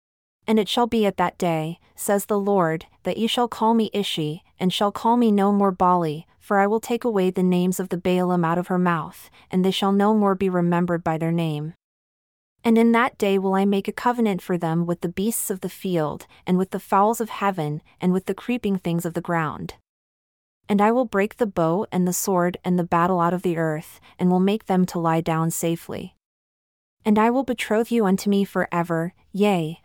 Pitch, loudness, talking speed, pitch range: 190 Hz, -22 LUFS, 225 wpm, 175-210 Hz